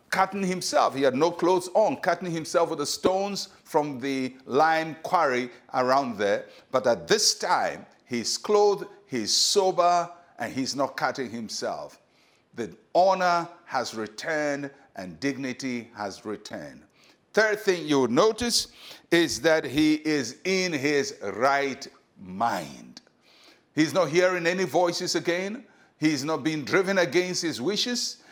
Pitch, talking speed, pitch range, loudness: 165 Hz, 140 wpm, 140-185 Hz, -25 LUFS